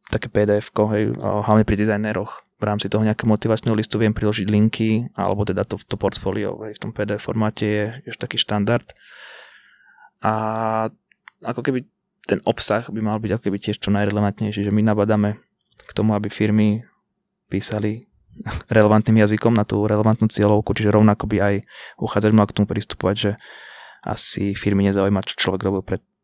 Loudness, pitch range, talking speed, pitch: -20 LUFS, 105-110 Hz, 165 wpm, 105 Hz